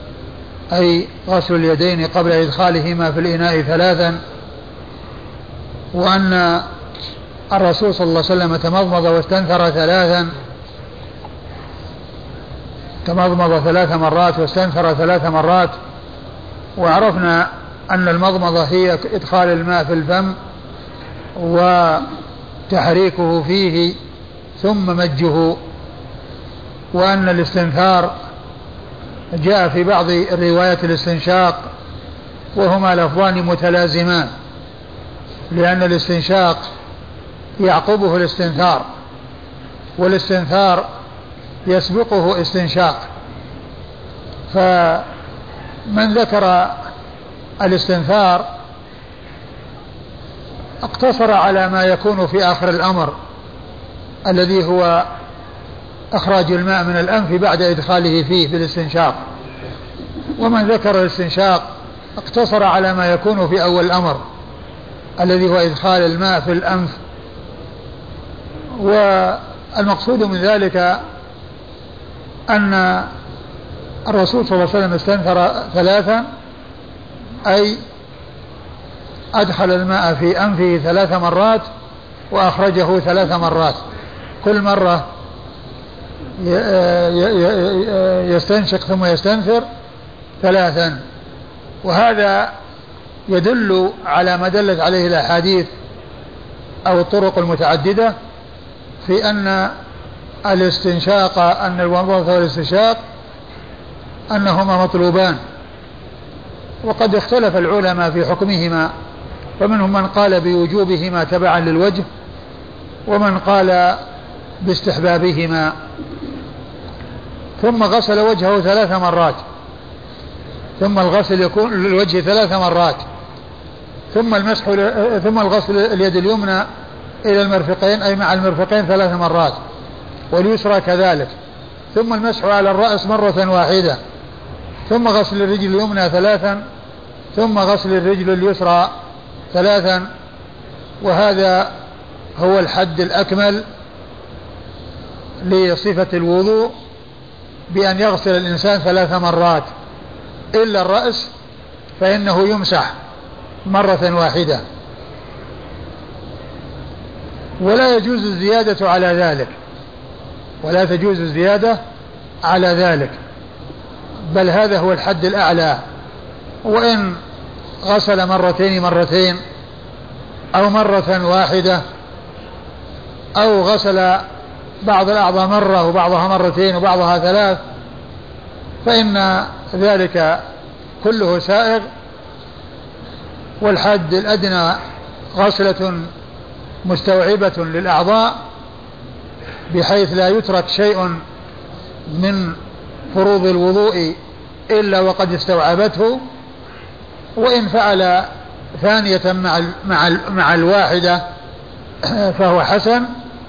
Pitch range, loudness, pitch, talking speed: 175-200 Hz, -14 LUFS, 185 Hz, 80 wpm